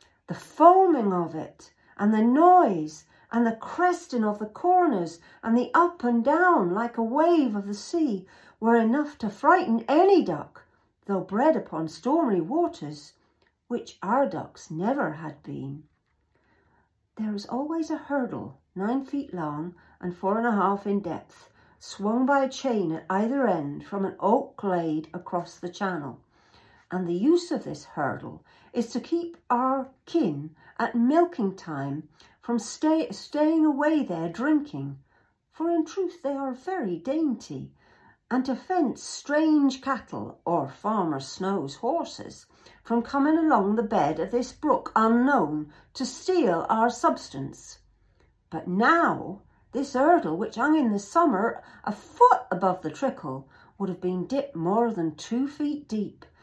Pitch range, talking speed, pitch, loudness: 180-295 Hz, 150 wpm, 235 Hz, -25 LUFS